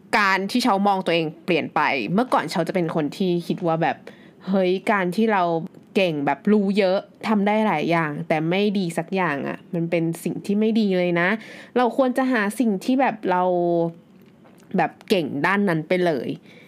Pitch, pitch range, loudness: 185 Hz, 170-210 Hz, -22 LUFS